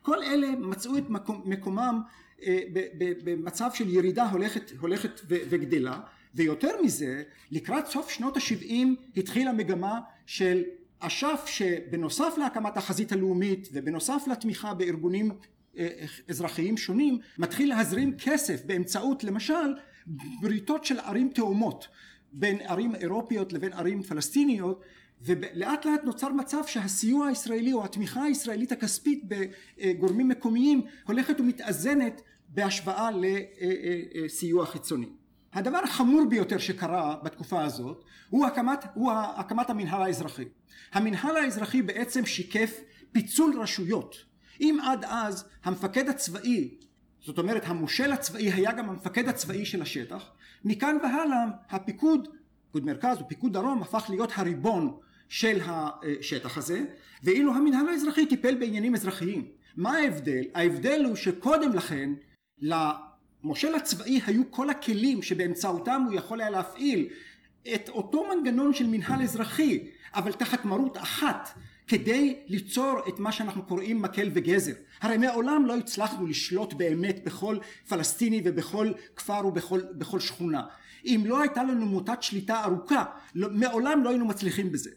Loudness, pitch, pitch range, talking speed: -29 LUFS, 220 Hz, 185-265 Hz, 120 wpm